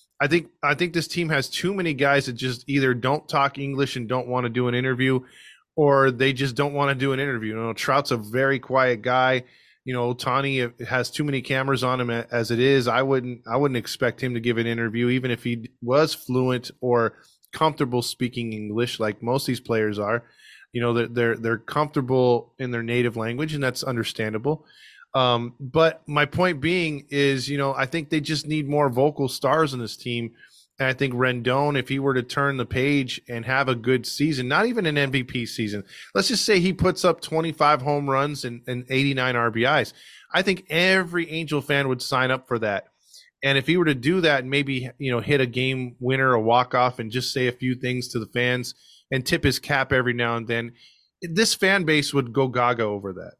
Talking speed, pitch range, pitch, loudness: 220 wpm, 120-145 Hz, 130 Hz, -23 LUFS